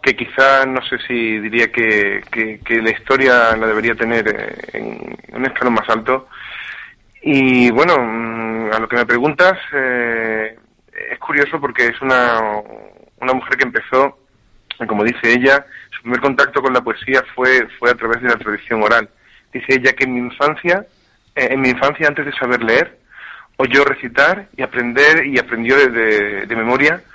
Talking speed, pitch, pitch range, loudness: 170 wpm, 120 Hz, 115-135 Hz, -15 LUFS